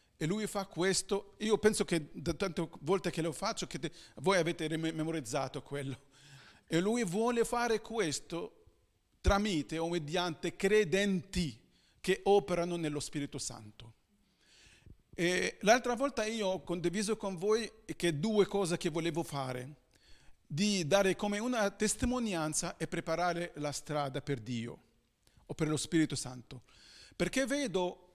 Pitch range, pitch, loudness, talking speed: 145-200 Hz, 175 Hz, -34 LUFS, 140 wpm